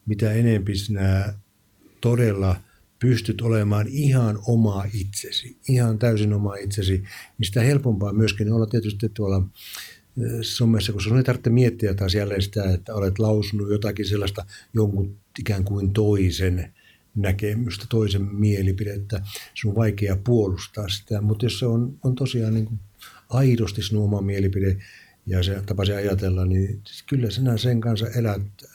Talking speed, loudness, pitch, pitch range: 145 wpm, -23 LUFS, 105 Hz, 100-115 Hz